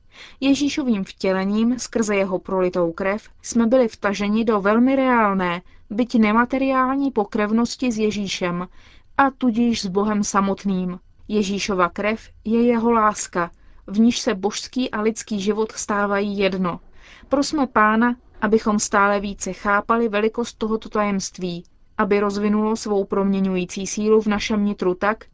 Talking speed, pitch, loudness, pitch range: 130 wpm, 210 Hz, -21 LUFS, 200-230 Hz